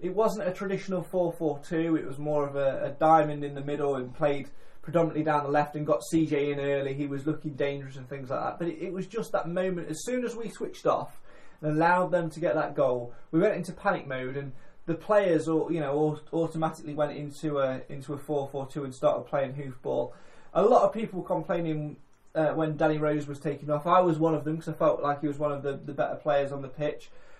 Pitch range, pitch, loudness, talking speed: 145-170 Hz, 150 Hz, -29 LUFS, 245 wpm